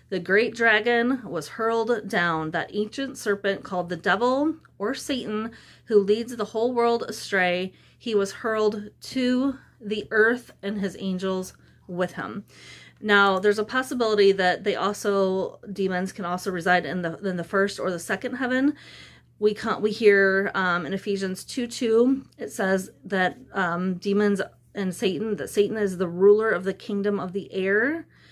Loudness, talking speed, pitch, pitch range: -24 LUFS, 165 wpm, 205 Hz, 190-225 Hz